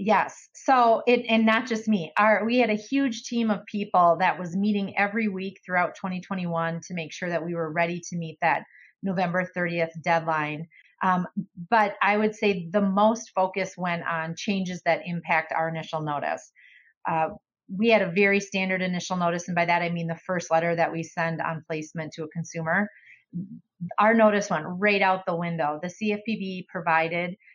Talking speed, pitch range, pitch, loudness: 185 wpm, 170-205 Hz, 185 Hz, -25 LUFS